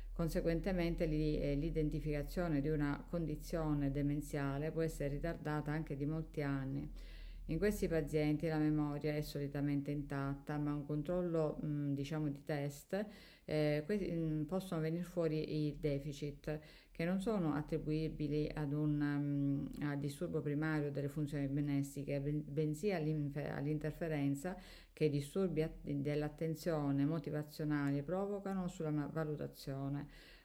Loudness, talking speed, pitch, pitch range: -39 LUFS, 120 wpm, 150 Hz, 145-160 Hz